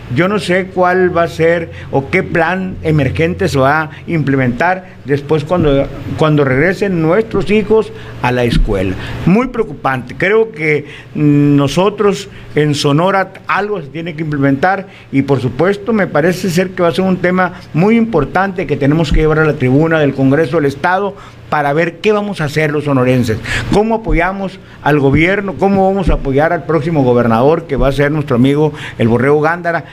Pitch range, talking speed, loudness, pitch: 140-185 Hz, 180 wpm, -13 LUFS, 160 Hz